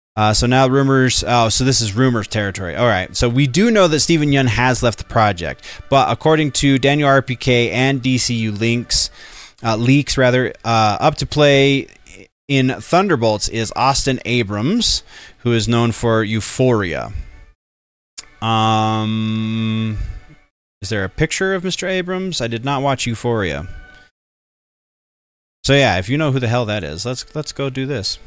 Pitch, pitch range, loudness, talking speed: 120 Hz, 110-135 Hz, -16 LUFS, 160 wpm